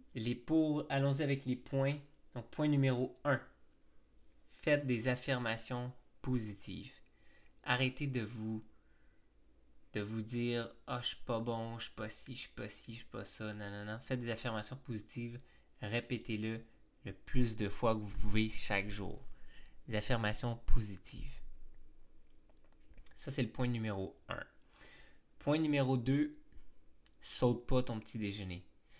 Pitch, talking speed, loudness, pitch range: 115 Hz, 155 wpm, -38 LUFS, 105-130 Hz